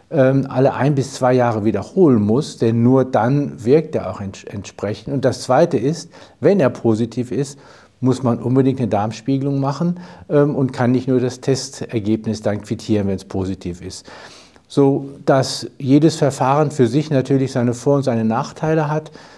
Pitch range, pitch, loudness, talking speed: 115-140 Hz, 130 Hz, -18 LUFS, 165 wpm